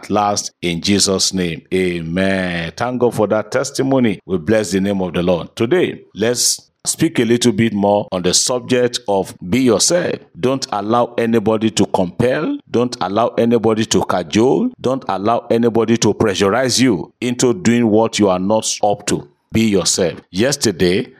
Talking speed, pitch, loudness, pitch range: 160 wpm, 110 Hz, -16 LUFS, 95-120 Hz